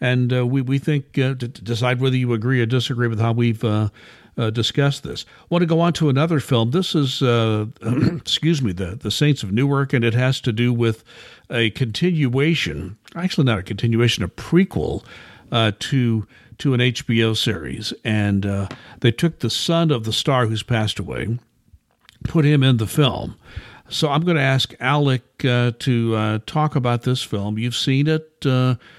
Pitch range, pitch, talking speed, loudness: 115-140 Hz, 125 Hz, 190 wpm, -20 LUFS